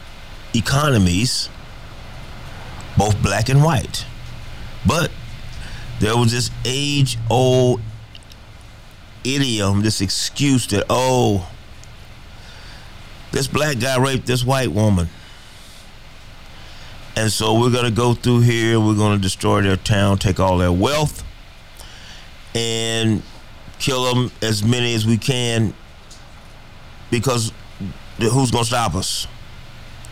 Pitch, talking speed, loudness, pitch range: 110 Hz, 110 wpm, -18 LUFS, 105-120 Hz